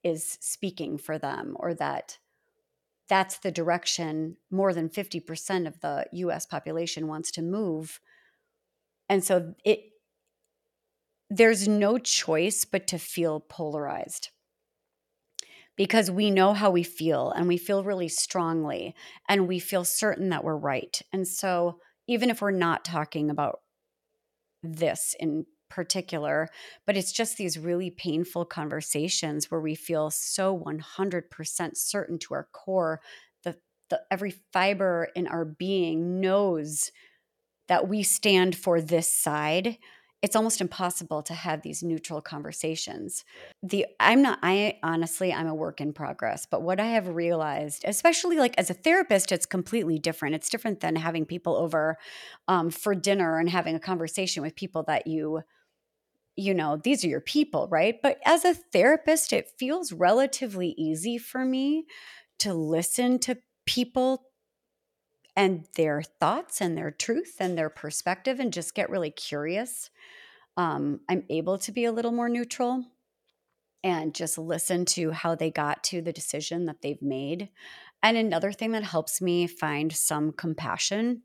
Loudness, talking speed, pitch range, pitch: -27 LUFS, 150 wpm, 160-225 Hz, 185 Hz